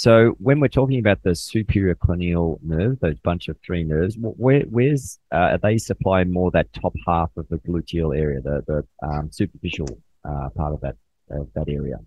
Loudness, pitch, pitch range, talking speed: -22 LUFS, 85 Hz, 75-105 Hz, 190 wpm